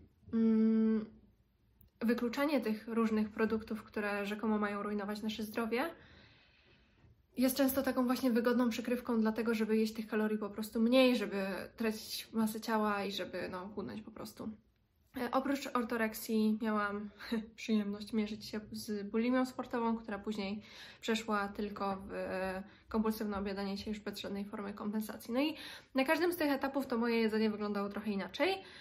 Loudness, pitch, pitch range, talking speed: -35 LUFS, 220 Hz, 210-240 Hz, 145 wpm